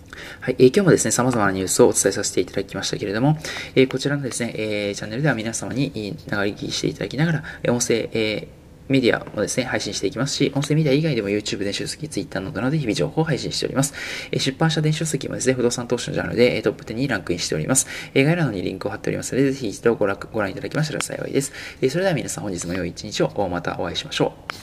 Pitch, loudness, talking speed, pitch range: 130 Hz, -22 LUFS, 550 characters per minute, 105-145 Hz